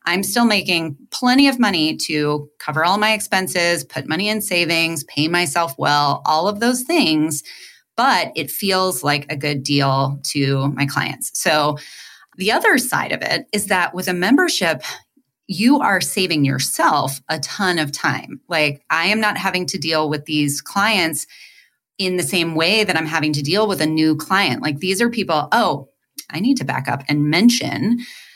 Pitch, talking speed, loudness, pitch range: 165 Hz, 180 wpm, -18 LUFS, 150-200 Hz